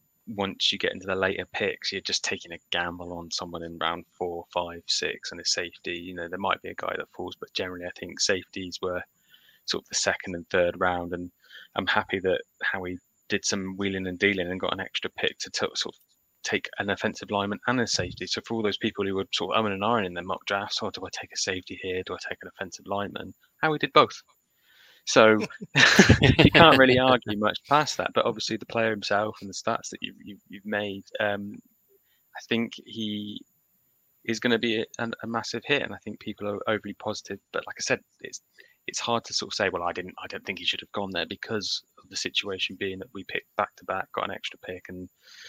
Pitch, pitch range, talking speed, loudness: 100 Hz, 90-110 Hz, 240 wpm, -26 LUFS